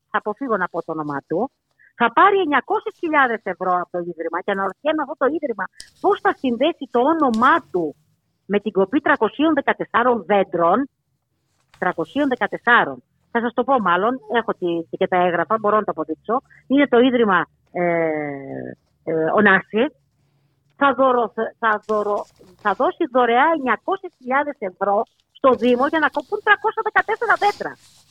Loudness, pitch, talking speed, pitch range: -20 LUFS, 225 Hz, 135 wpm, 175-280 Hz